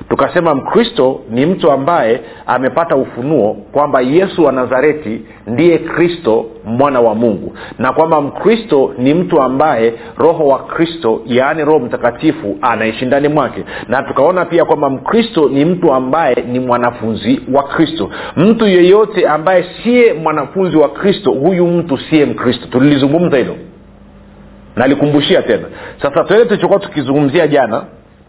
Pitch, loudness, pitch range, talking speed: 150 Hz, -12 LUFS, 125-175 Hz, 135 wpm